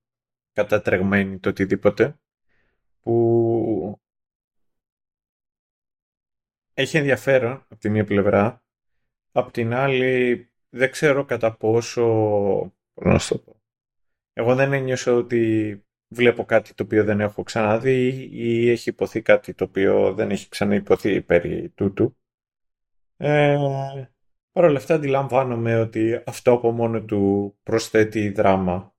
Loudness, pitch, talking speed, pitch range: -21 LUFS, 115 Hz, 110 wpm, 105-125 Hz